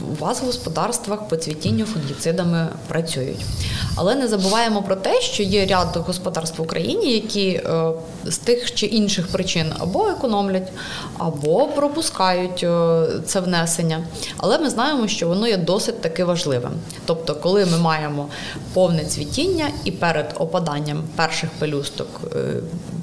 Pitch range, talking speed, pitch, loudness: 160-200 Hz, 135 wpm, 170 Hz, -21 LUFS